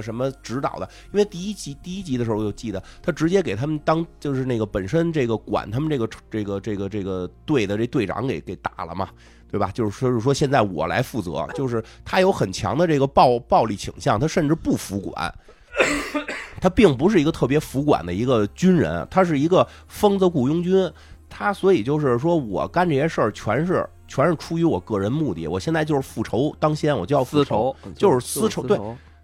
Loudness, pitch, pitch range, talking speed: -22 LUFS, 135 Hz, 105-160 Hz, 320 characters per minute